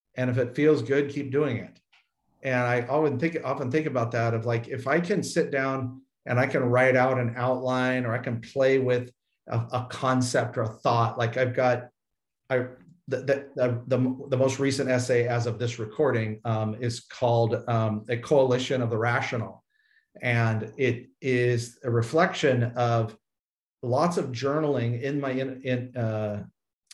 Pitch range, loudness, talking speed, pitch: 120-135 Hz, -26 LUFS, 175 wpm, 125 Hz